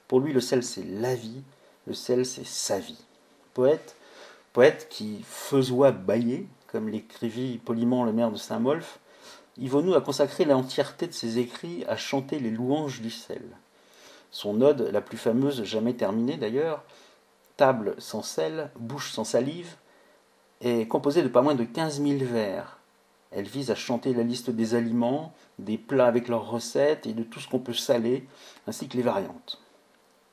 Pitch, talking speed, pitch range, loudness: 125 Hz, 165 wpm, 115-135 Hz, -27 LUFS